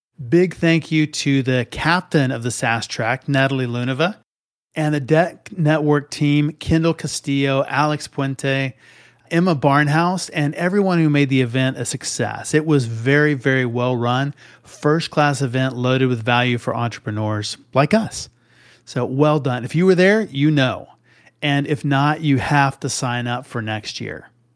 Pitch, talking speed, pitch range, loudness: 140 Hz, 160 wpm, 125-155 Hz, -19 LUFS